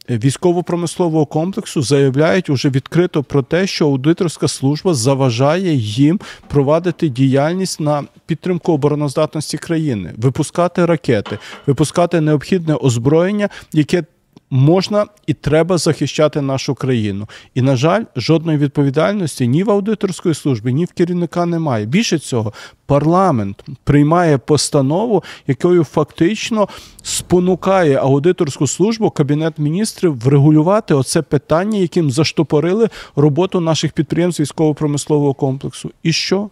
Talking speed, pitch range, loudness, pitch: 110 wpm, 140-175 Hz, -15 LUFS, 155 Hz